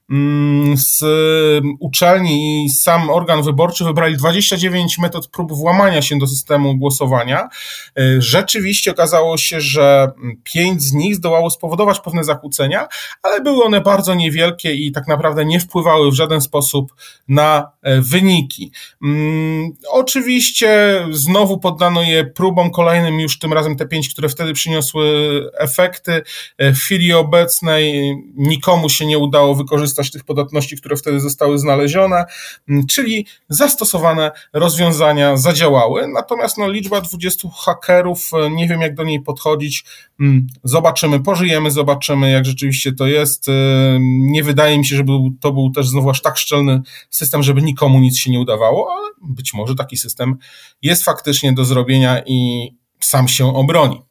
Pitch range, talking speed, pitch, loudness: 140-170 Hz, 140 wpm, 150 Hz, -14 LUFS